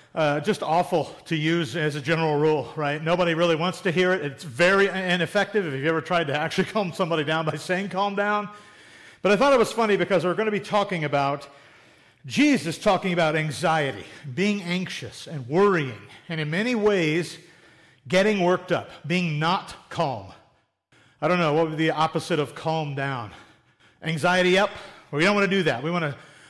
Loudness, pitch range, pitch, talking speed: -24 LUFS, 155-190 Hz, 165 Hz, 190 wpm